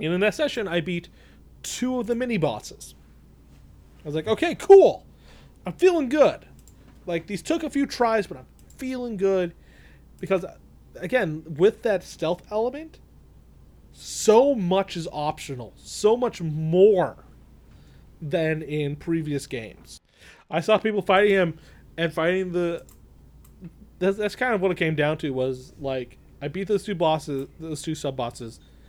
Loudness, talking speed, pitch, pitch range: -24 LUFS, 150 wpm, 170 Hz, 145-210 Hz